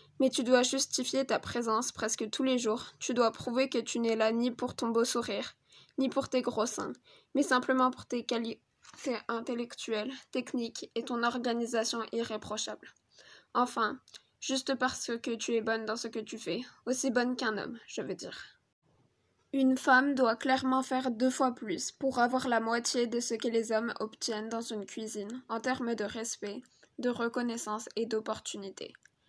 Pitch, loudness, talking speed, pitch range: 240 Hz, -32 LUFS, 175 wpm, 225-255 Hz